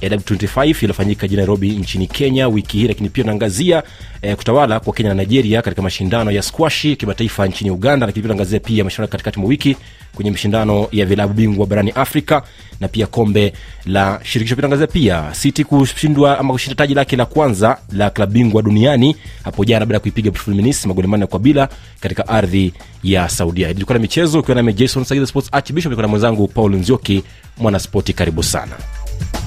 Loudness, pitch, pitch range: -15 LUFS, 110 Hz, 100-130 Hz